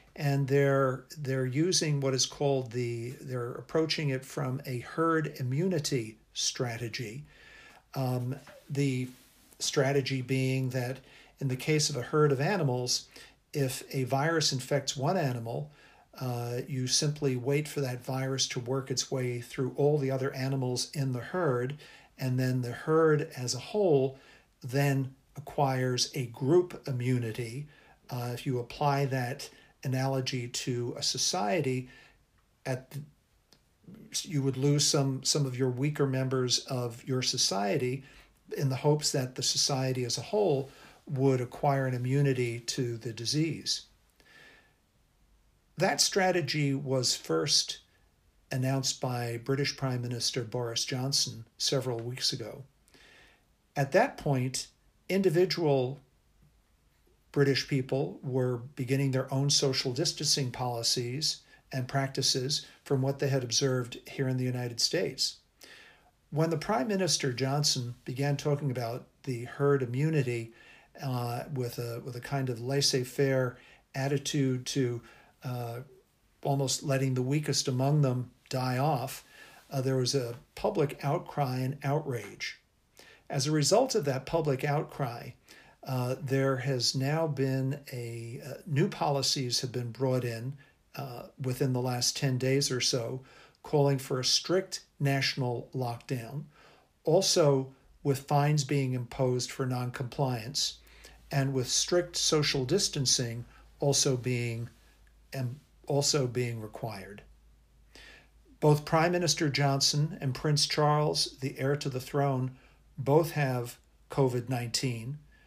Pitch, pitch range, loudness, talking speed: 135 Hz, 125-145 Hz, -30 LUFS, 130 wpm